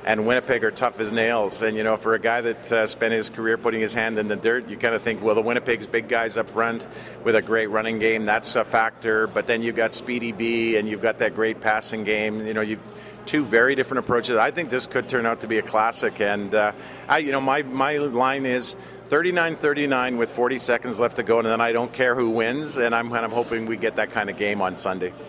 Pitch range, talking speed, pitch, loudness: 110-120 Hz, 255 wpm, 115 Hz, -23 LUFS